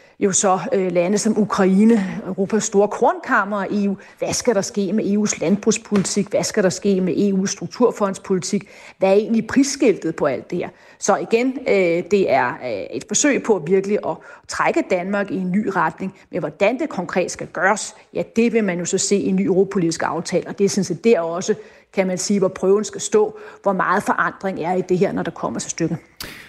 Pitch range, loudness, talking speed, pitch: 190-215 Hz, -19 LUFS, 205 wpm, 200 Hz